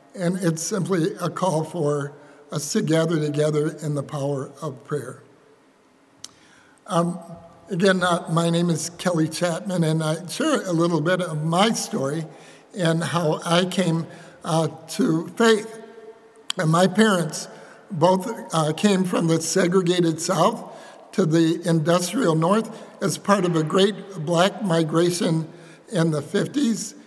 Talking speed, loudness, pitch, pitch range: 140 wpm, -22 LUFS, 170 Hz, 160-190 Hz